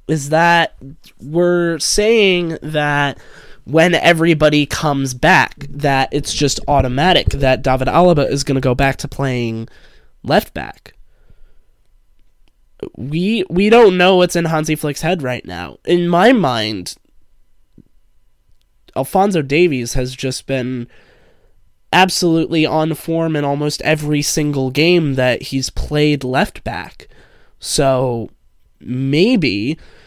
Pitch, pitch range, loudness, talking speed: 145 Hz, 130-170 Hz, -15 LUFS, 120 wpm